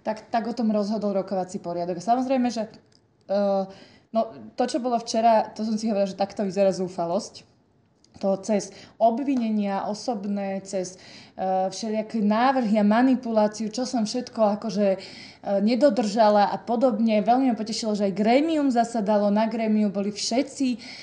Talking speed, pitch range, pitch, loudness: 150 wpm, 200-235 Hz, 215 Hz, -24 LUFS